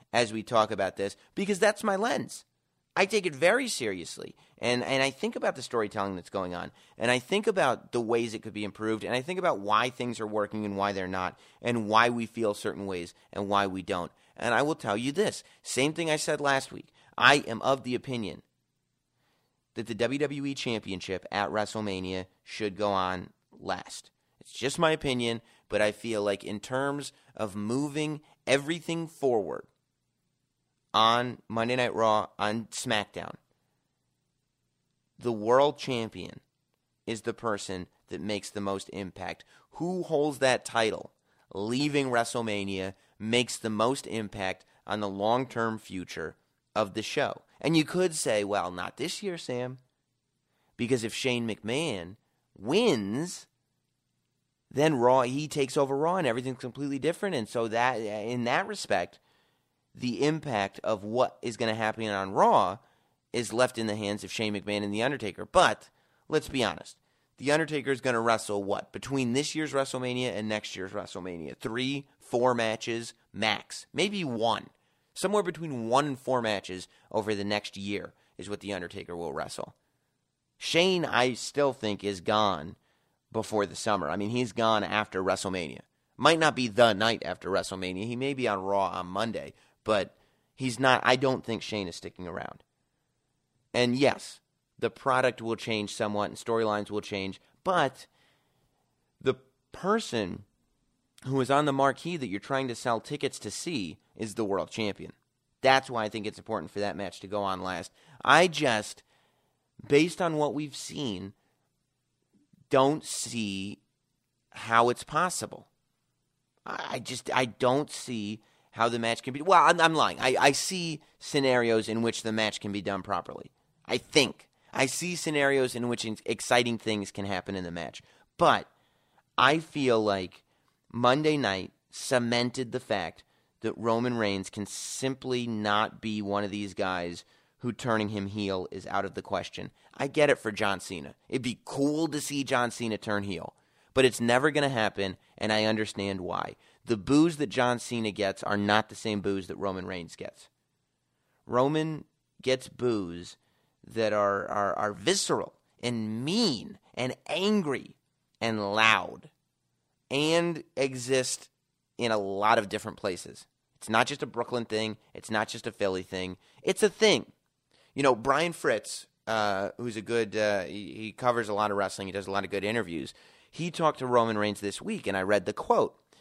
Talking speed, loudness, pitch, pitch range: 170 wpm, -29 LUFS, 115 Hz, 105-135 Hz